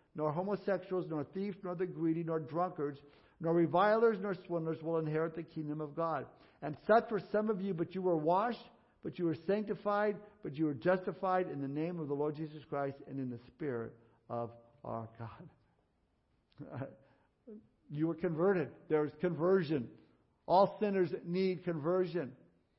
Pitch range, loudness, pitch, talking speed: 150-190 Hz, -35 LUFS, 170 Hz, 165 wpm